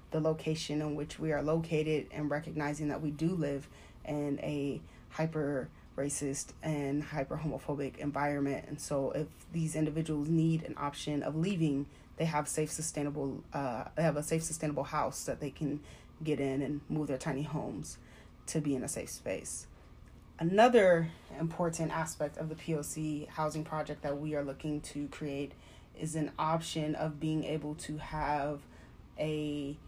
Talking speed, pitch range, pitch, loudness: 165 wpm, 145-155 Hz, 150 Hz, -35 LUFS